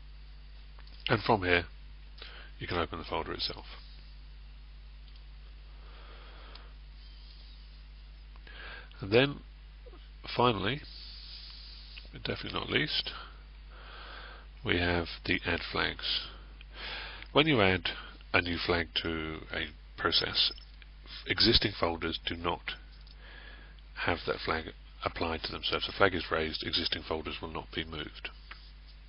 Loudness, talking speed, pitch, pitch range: -31 LUFS, 105 wpm, 75 Hz, 75-85 Hz